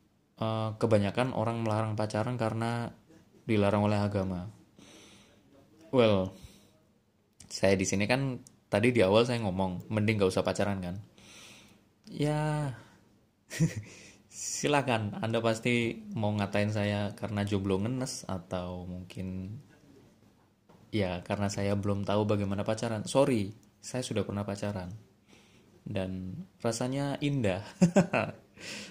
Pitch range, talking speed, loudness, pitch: 100-115 Hz, 105 wpm, -31 LUFS, 105 Hz